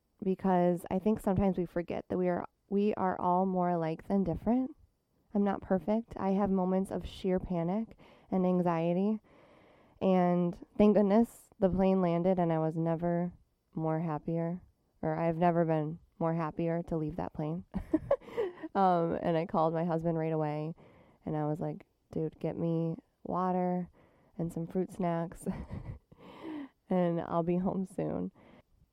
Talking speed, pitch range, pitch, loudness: 155 wpm, 165-190 Hz, 175 Hz, -32 LUFS